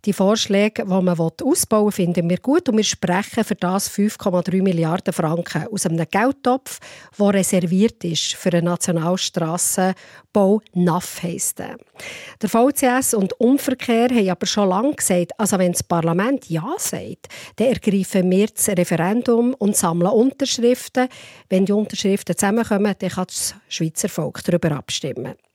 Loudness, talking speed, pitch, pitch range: -19 LUFS, 145 wpm, 195 Hz, 175-220 Hz